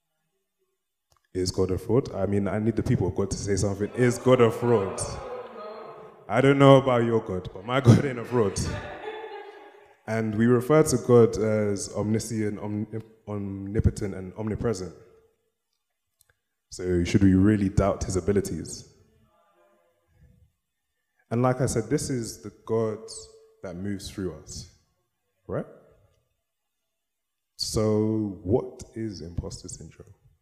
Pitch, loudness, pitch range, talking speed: 110 Hz, -25 LUFS, 100-130 Hz, 130 wpm